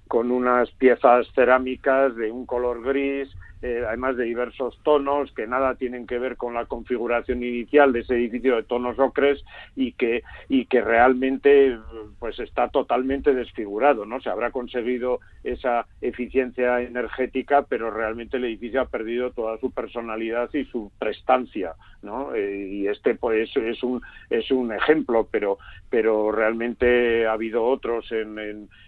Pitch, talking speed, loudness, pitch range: 125 Hz, 155 wpm, -23 LUFS, 115-130 Hz